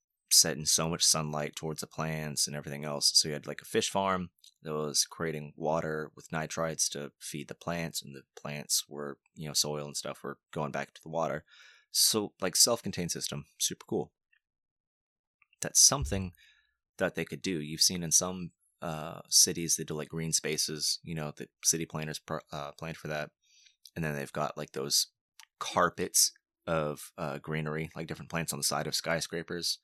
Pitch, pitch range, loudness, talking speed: 80 Hz, 75-85 Hz, -30 LUFS, 185 wpm